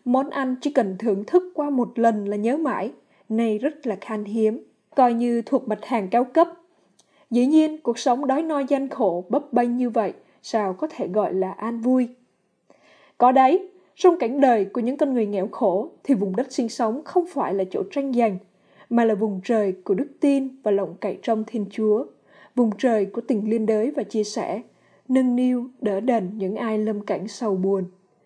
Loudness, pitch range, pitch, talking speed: -23 LUFS, 210-265 Hz, 235 Hz, 205 wpm